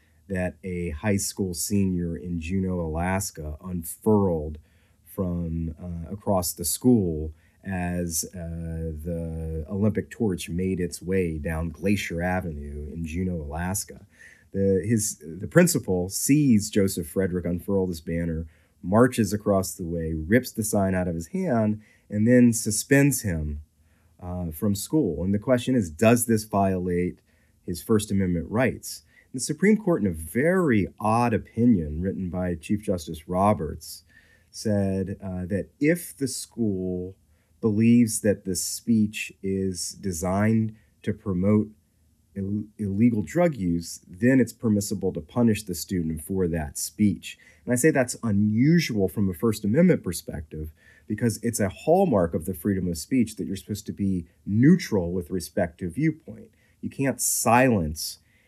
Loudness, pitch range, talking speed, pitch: -25 LUFS, 85-110 Hz, 145 wpm, 95 Hz